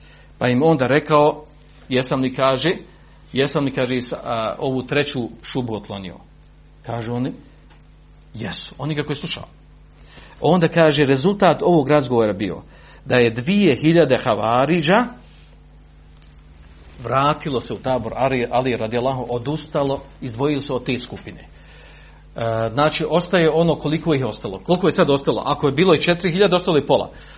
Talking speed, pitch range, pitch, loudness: 150 wpm, 110-155 Hz, 135 Hz, -19 LUFS